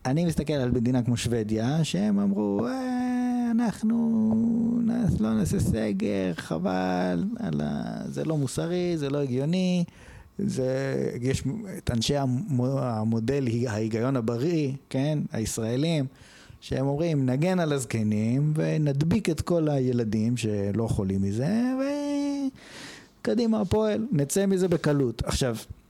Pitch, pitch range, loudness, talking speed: 140 Hz, 120-190 Hz, -26 LUFS, 110 wpm